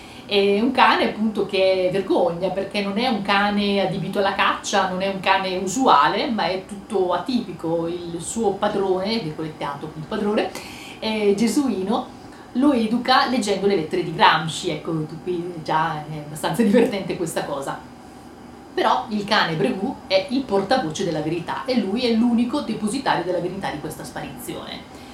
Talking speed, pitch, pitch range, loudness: 160 wpm, 195 Hz, 180-230 Hz, -21 LUFS